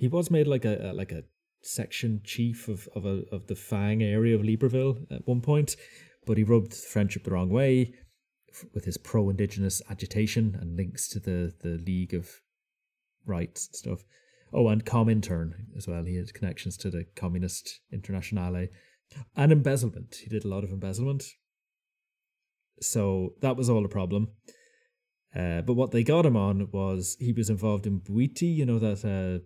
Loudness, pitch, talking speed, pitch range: -28 LUFS, 105 Hz, 175 wpm, 95-120 Hz